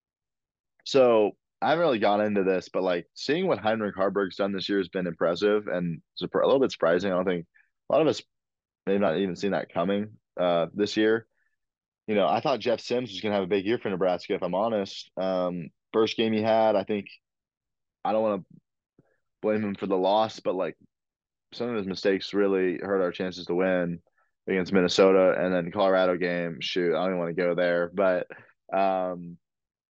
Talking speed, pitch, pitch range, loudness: 210 wpm, 95 Hz, 90-105 Hz, -26 LUFS